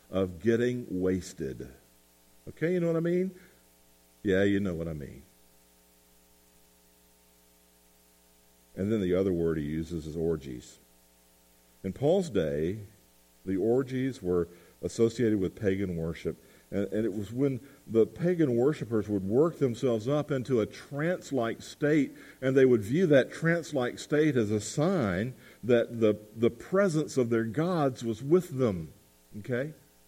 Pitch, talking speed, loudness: 105 Hz, 145 wpm, -29 LUFS